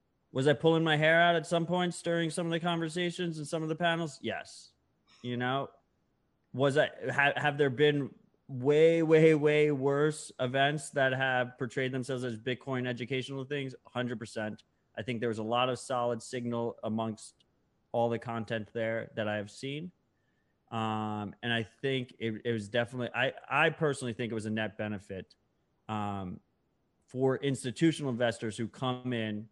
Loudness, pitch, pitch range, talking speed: -31 LUFS, 130 Hz, 115-150 Hz, 175 wpm